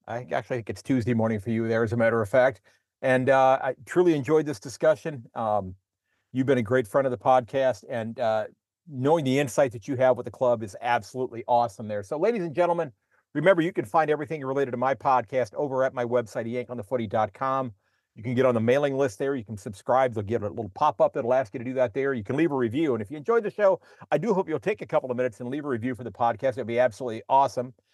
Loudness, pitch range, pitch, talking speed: -26 LUFS, 115-140 Hz, 130 Hz, 250 wpm